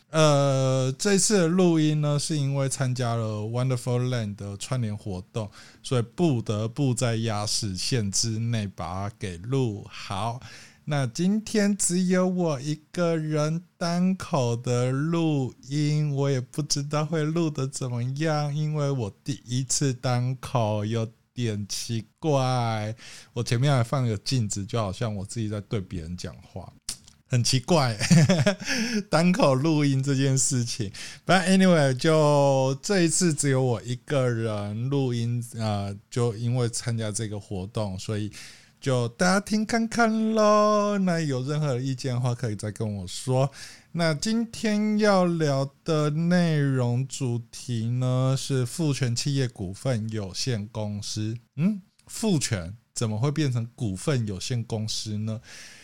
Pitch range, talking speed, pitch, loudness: 115-155 Hz, 225 characters per minute, 130 Hz, -25 LUFS